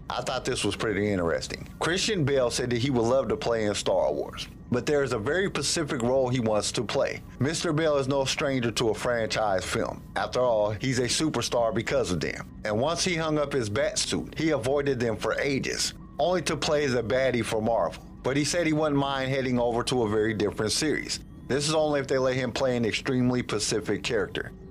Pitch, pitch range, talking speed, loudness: 135 Hz, 120-150 Hz, 220 wpm, -27 LUFS